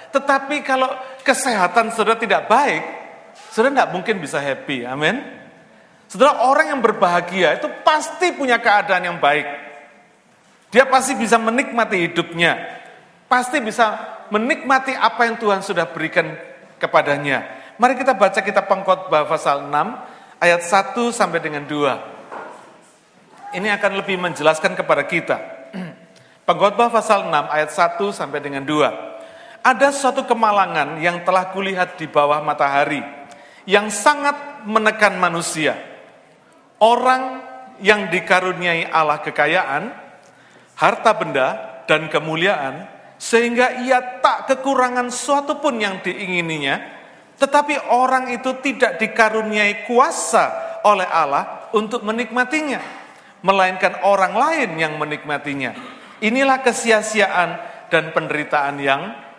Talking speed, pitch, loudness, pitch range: 115 wpm, 205 Hz, -18 LUFS, 170-255 Hz